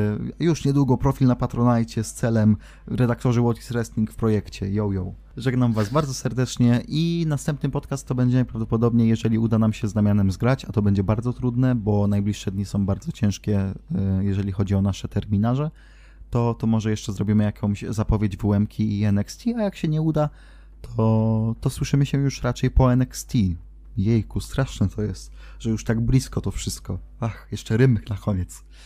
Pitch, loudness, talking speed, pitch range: 110 Hz, -23 LUFS, 180 wpm, 100-125 Hz